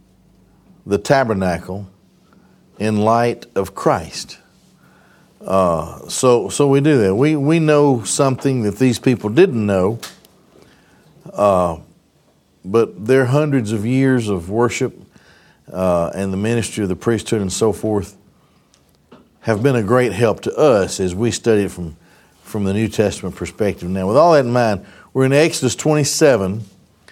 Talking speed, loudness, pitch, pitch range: 145 wpm, -17 LUFS, 110 Hz, 95-130 Hz